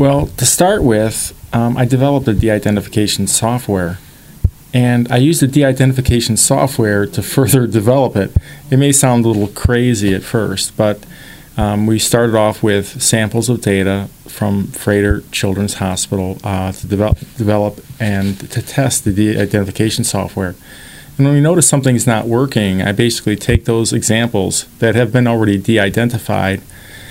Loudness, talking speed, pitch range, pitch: -14 LUFS, 160 wpm, 100-125 Hz, 110 Hz